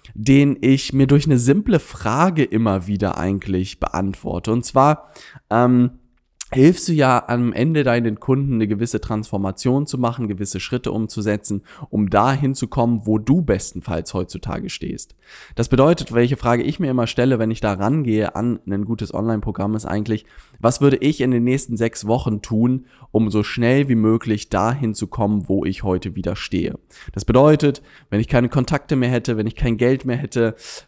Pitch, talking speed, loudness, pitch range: 115 Hz, 180 wpm, -19 LUFS, 105-130 Hz